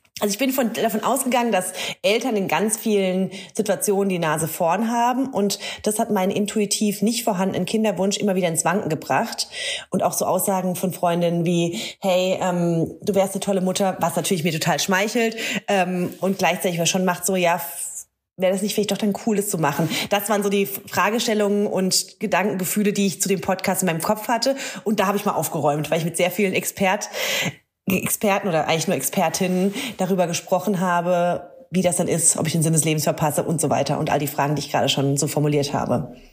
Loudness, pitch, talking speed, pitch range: -21 LUFS, 190 Hz, 210 wpm, 170-205 Hz